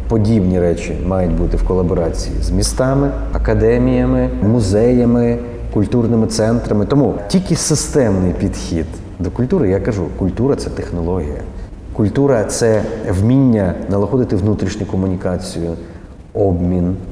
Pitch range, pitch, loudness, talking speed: 90-120 Hz, 100 Hz, -16 LUFS, 105 wpm